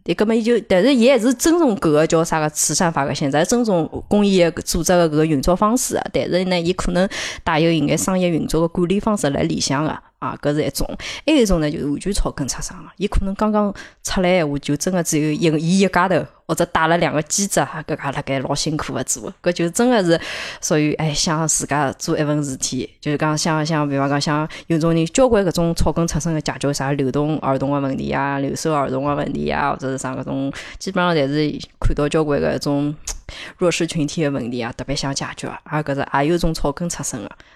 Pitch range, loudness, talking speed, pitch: 145-180 Hz, -19 LUFS, 340 characters per minute, 155 Hz